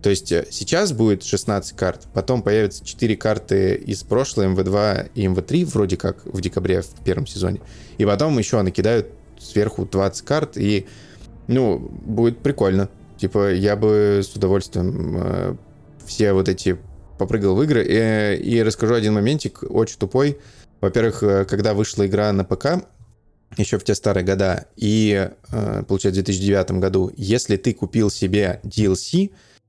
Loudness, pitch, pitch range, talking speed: -20 LUFS, 105 Hz, 95-115 Hz, 150 wpm